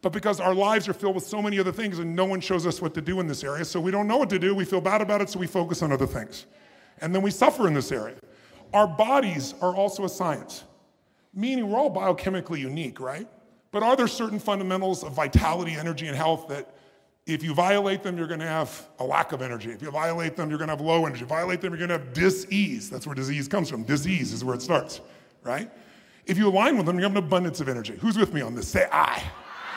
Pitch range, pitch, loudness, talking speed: 155-200 Hz, 180 Hz, -26 LUFS, 260 wpm